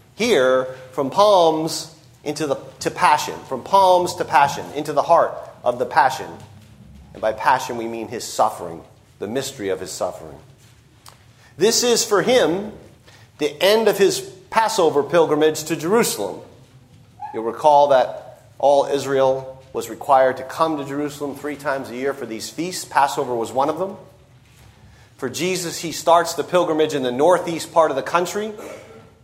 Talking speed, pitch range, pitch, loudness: 160 wpm, 125-165 Hz, 145 Hz, -19 LUFS